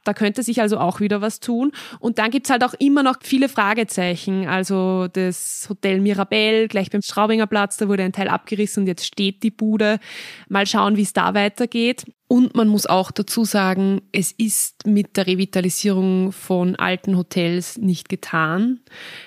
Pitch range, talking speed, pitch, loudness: 190-220 Hz, 180 wpm, 205 Hz, -19 LUFS